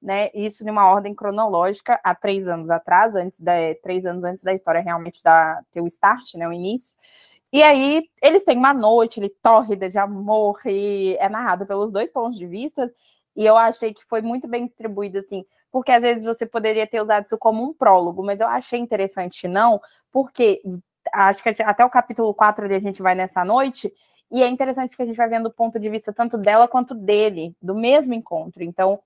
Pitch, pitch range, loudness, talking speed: 215 Hz, 190-235 Hz, -19 LUFS, 200 wpm